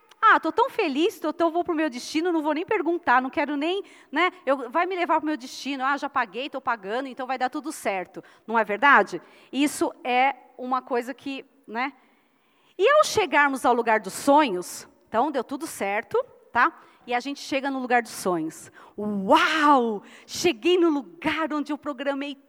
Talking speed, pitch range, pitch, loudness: 190 wpm, 250-325 Hz, 280 Hz, -24 LUFS